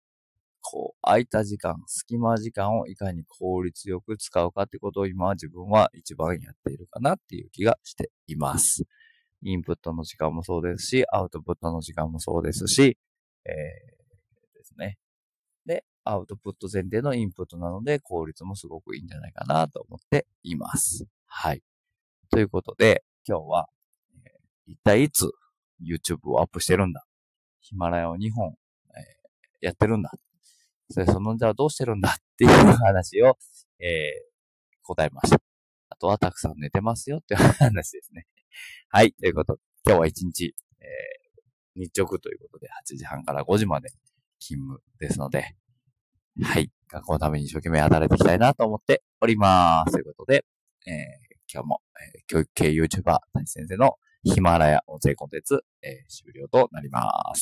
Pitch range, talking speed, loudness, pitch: 85-135 Hz, 350 characters per minute, -24 LUFS, 100 Hz